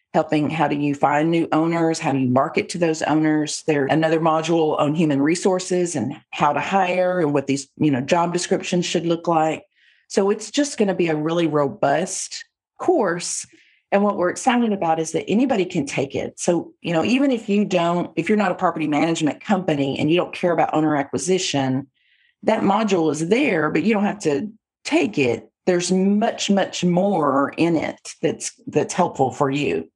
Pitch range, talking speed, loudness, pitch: 150-195 Hz, 195 wpm, -20 LUFS, 170 Hz